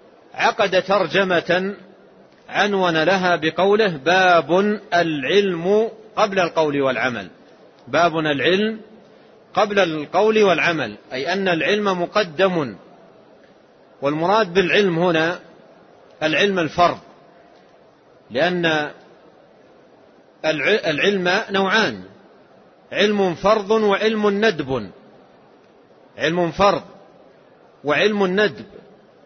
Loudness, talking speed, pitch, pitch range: -19 LUFS, 70 wpm, 185 Hz, 165-200 Hz